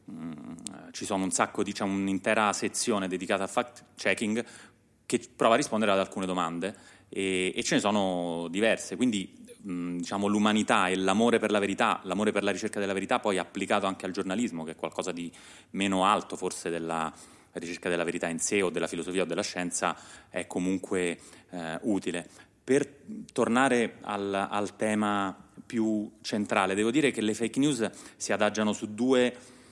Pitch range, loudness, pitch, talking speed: 90-110 Hz, -29 LUFS, 100 Hz, 170 wpm